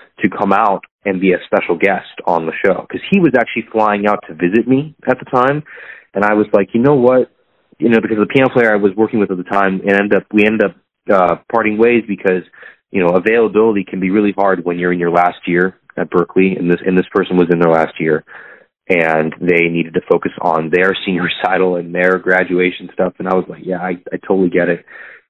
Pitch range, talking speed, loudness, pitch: 90-110 Hz, 240 wpm, -14 LUFS, 95 Hz